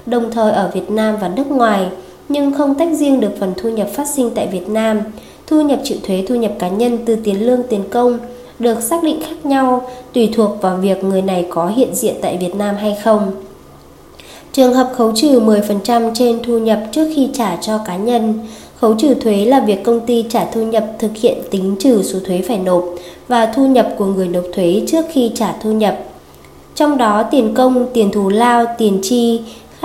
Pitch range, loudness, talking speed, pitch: 205-250 Hz, -15 LUFS, 215 wpm, 225 Hz